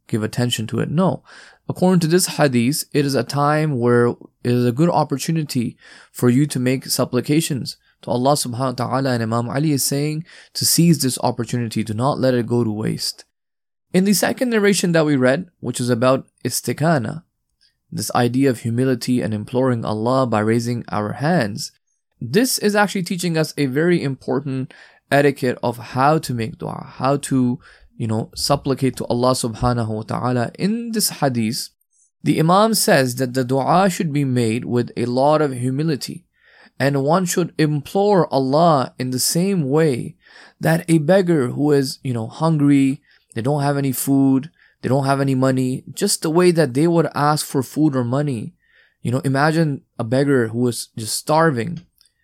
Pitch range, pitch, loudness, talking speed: 125-155 Hz, 135 Hz, -19 LUFS, 180 wpm